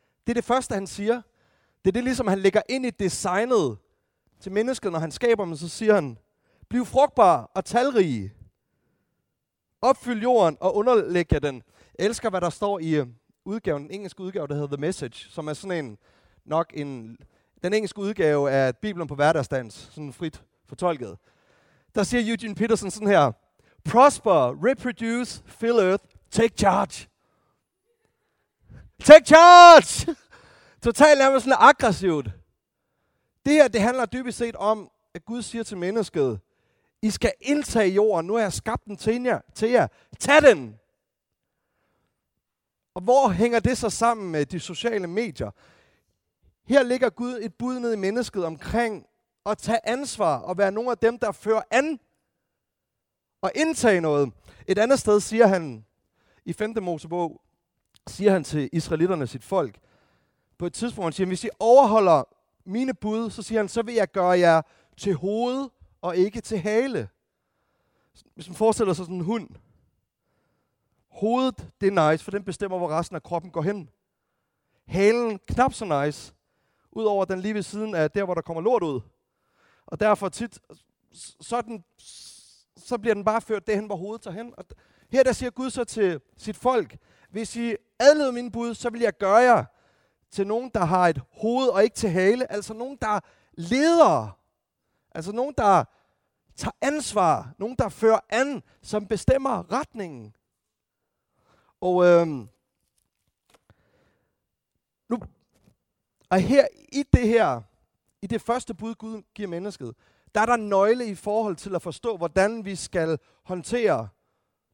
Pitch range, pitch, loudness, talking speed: 170-235 Hz, 210 Hz, -22 LUFS, 155 wpm